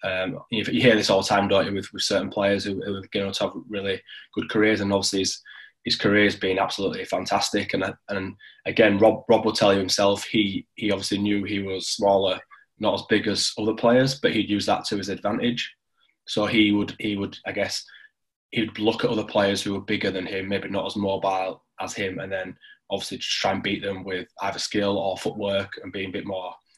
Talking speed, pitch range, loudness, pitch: 225 wpm, 95-105 Hz, -24 LUFS, 100 Hz